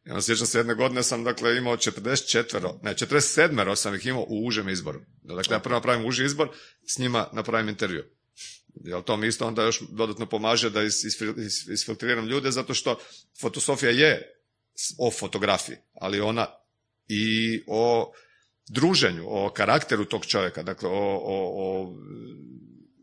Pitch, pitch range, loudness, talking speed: 115 Hz, 110-120 Hz, -25 LUFS, 150 wpm